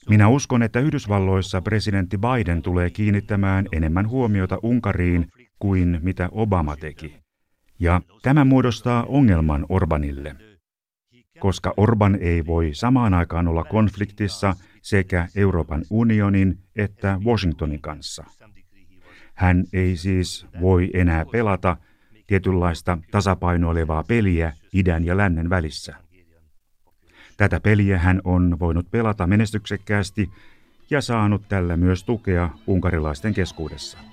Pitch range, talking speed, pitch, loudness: 85-105 Hz, 105 wpm, 95 Hz, -21 LUFS